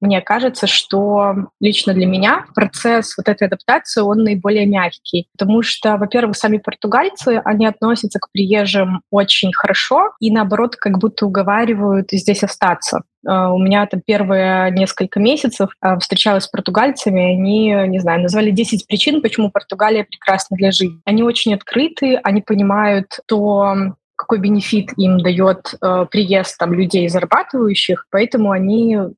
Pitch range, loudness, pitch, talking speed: 195-220 Hz, -15 LUFS, 205 Hz, 140 wpm